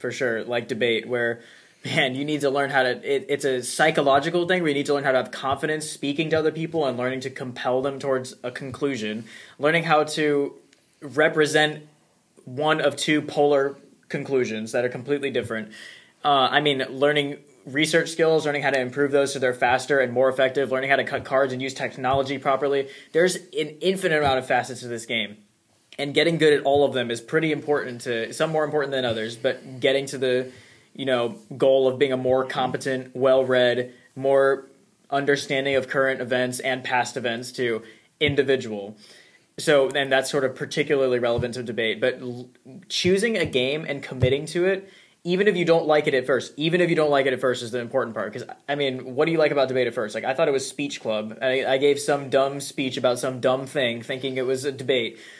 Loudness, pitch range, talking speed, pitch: -23 LUFS, 125-145 Hz, 210 wpm, 135 Hz